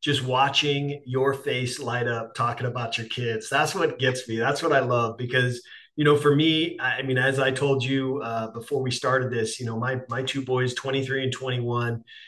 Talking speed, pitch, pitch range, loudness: 210 wpm, 130 Hz, 120-135 Hz, -25 LUFS